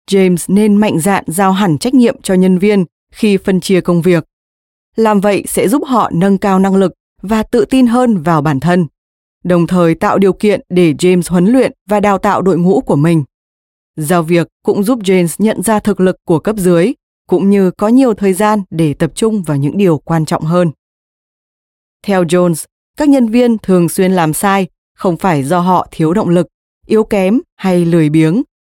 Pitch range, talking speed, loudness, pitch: 170-210 Hz, 200 wpm, -12 LUFS, 185 Hz